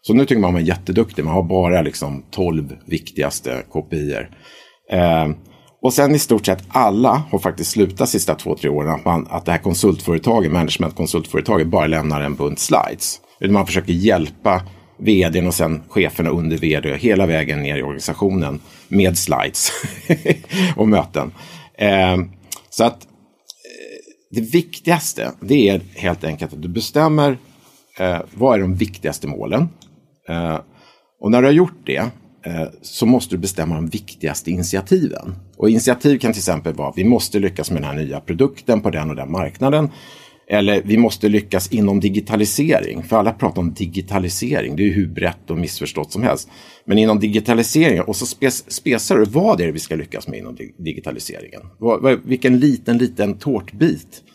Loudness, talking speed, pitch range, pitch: -18 LUFS, 170 wpm, 80-115 Hz, 95 Hz